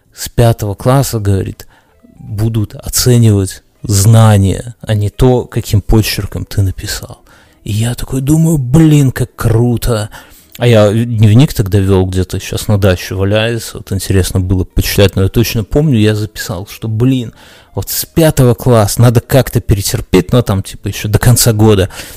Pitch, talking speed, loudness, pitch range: 110 Hz, 155 wpm, -11 LUFS, 100-120 Hz